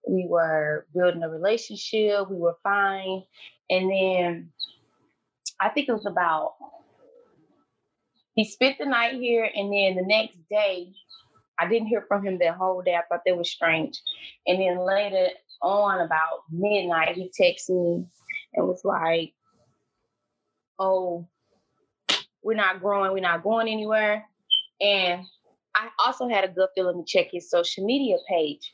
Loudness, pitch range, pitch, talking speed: -25 LUFS, 175-220 Hz, 190 Hz, 150 wpm